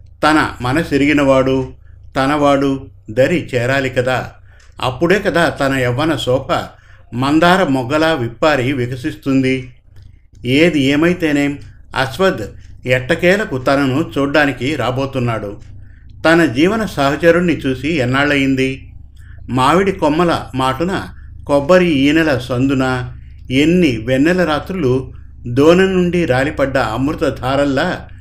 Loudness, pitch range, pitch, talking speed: -15 LUFS, 125-155 Hz, 135 Hz, 85 wpm